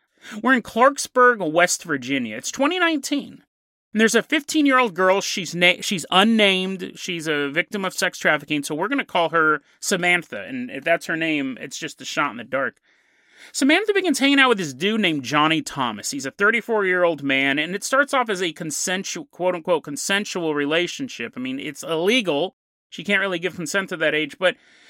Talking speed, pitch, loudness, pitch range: 185 wpm, 190 Hz, -21 LUFS, 165-250 Hz